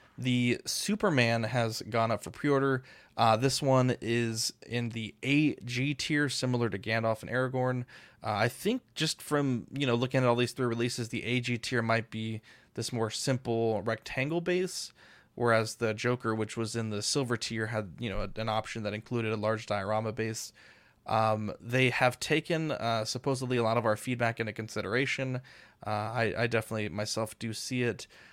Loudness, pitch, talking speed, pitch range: -31 LUFS, 115 Hz, 180 wpm, 110-130 Hz